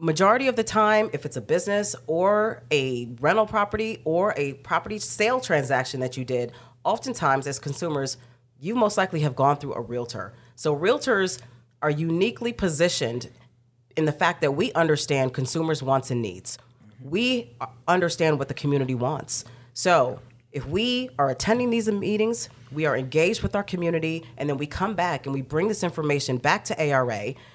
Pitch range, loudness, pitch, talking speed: 130-190 Hz, -24 LUFS, 150 Hz, 170 wpm